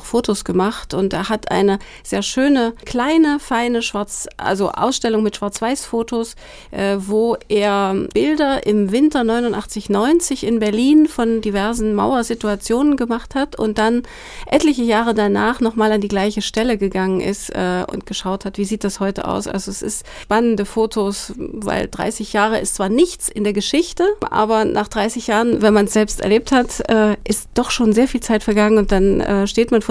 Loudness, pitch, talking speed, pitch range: -17 LUFS, 220 Hz, 180 wpm, 205-240 Hz